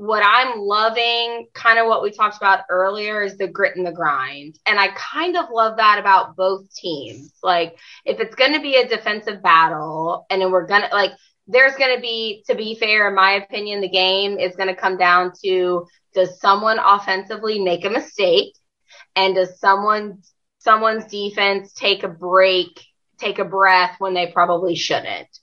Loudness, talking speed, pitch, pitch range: -17 LUFS, 180 wpm, 195 Hz, 185-220 Hz